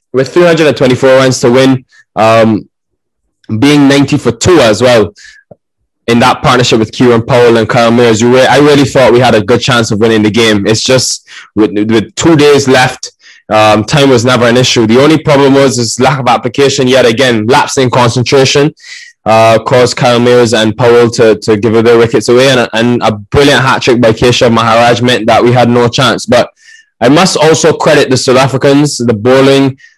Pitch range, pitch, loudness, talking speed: 115-135 Hz, 125 Hz, -6 LUFS, 195 wpm